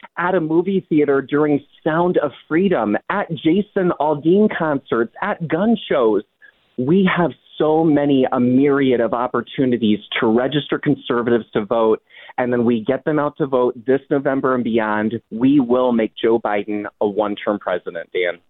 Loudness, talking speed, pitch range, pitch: -18 LUFS, 160 wpm, 120-165 Hz, 140 Hz